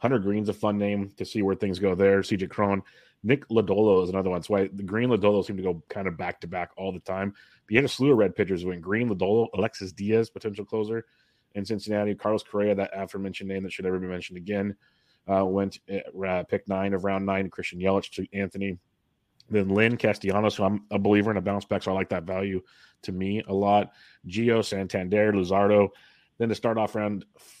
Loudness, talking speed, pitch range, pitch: -26 LUFS, 225 wpm, 95-105 Hz, 100 Hz